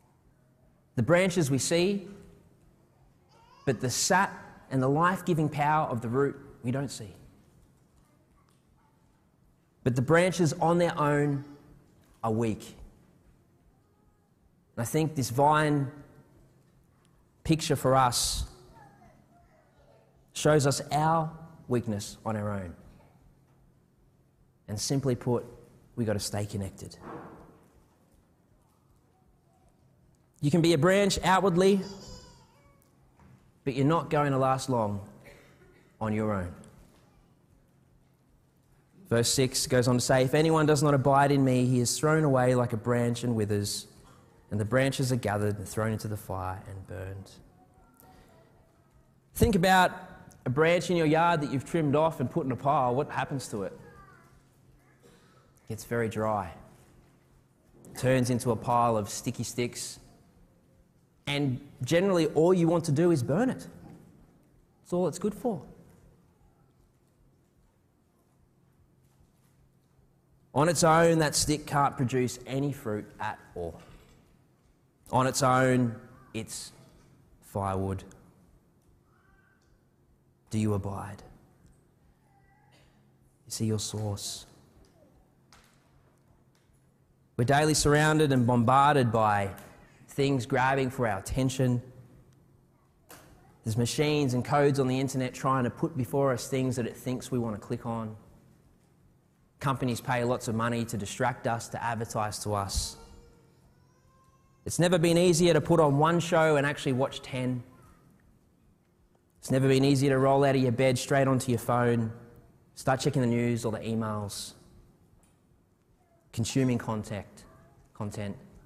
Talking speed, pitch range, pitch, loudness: 125 wpm, 115-150 Hz, 130 Hz, -27 LUFS